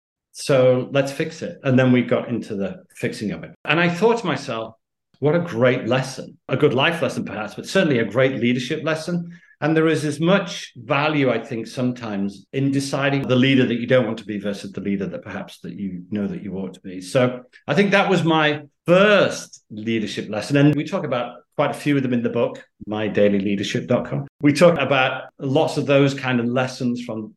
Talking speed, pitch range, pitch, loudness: 215 wpm, 115-150 Hz, 130 Hz, -20 LUFS